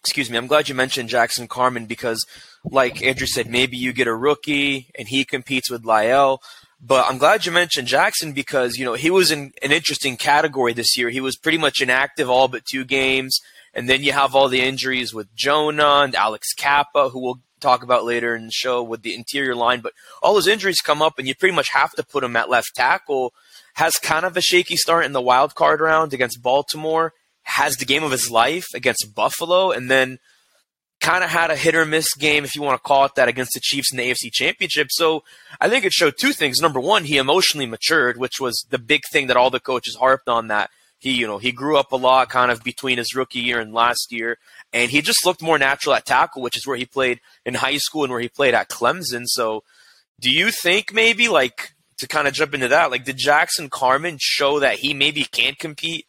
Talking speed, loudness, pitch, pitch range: 230 wpm, -18 LUFS, 130 Hz, 125-150 Hz